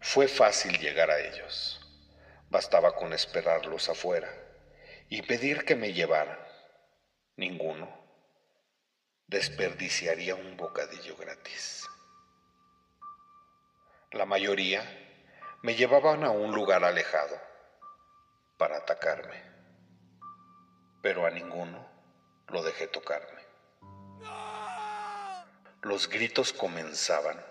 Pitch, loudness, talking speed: 140 Hz, -30 LUFS, 85 wpm